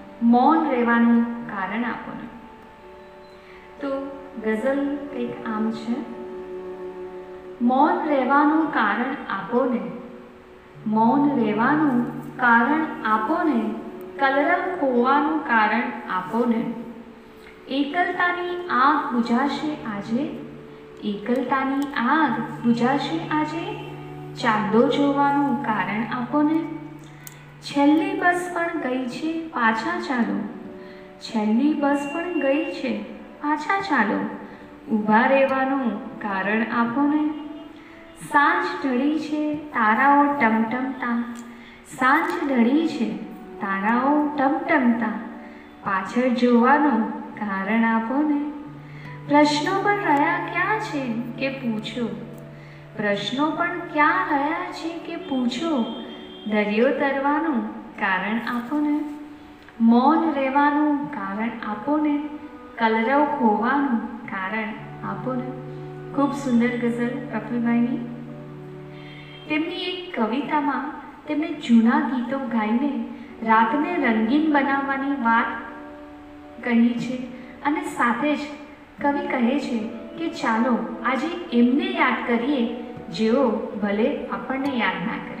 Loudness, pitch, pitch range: -22 LUFS, 255 Hz, 225-290 Hz